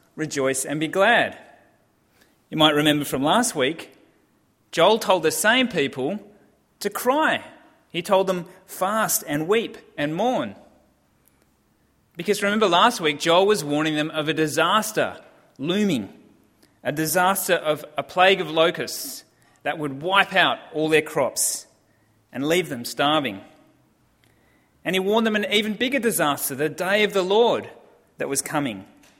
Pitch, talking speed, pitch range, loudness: 175 Hz, 145 wpm, 150-205 Hz, -22 LUFS